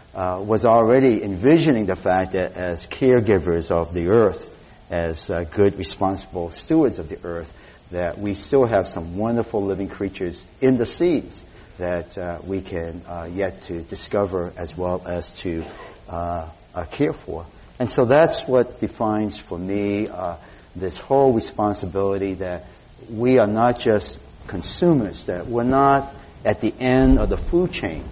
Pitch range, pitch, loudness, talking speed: 85-115 Hz, 95 Hz, -21 LUFS, 160 wpm